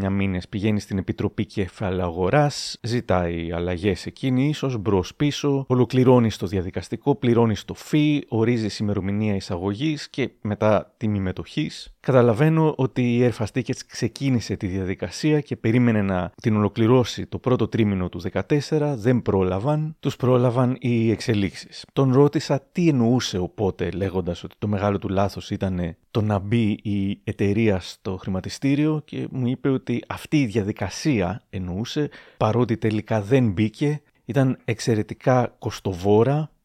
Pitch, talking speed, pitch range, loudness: 110 Hz, 135 wpm, 100-130 Hz, -23 LUFS